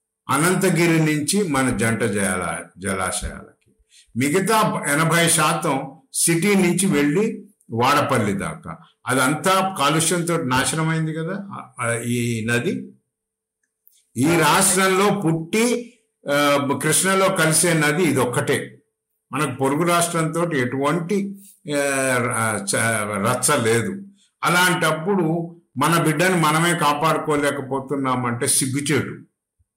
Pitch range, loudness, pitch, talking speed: 130-180 Hz, -19 LUFS, 155 Hz, 80 wpm